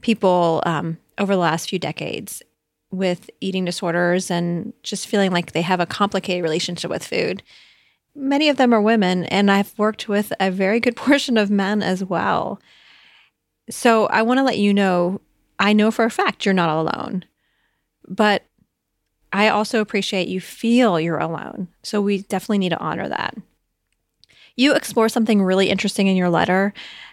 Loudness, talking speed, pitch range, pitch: -19 LUFS, 170 wpm, 180-220 Hz, 200 Hz